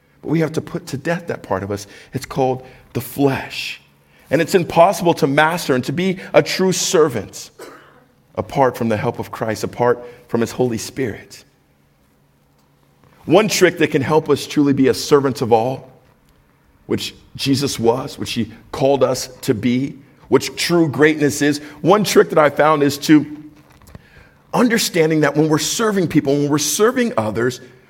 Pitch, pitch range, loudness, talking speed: 140 Hz, 120-155 Hz, -17 LUFS, 170 wpm